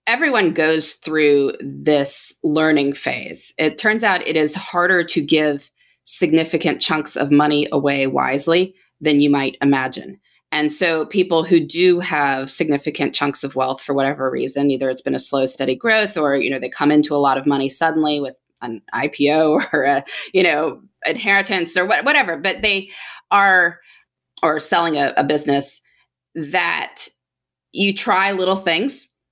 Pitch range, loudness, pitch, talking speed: 140-175 Hz, -17 LUFS, 150 Hz, 160 wpm